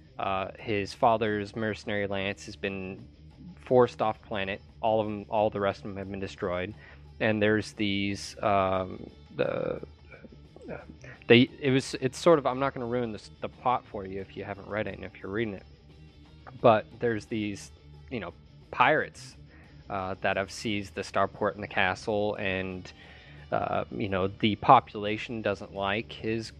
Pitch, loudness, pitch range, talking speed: 100 Hz, -29 LUFS, 95-110 Hz, 175 wpm